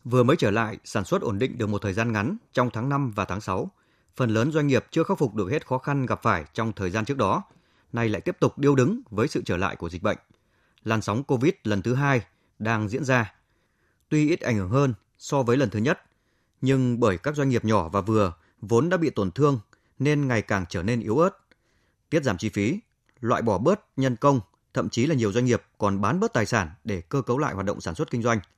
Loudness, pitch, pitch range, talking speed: -25 LUFS, 120 Hz, 105-135 Hz, 250 wpm